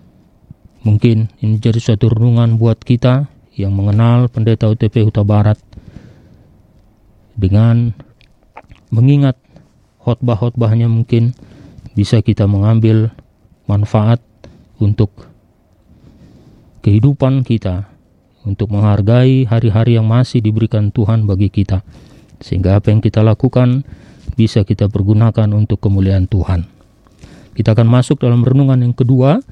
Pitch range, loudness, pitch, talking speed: 105-120 Hz, -13 LUFS, 110 Hz, 105 wpm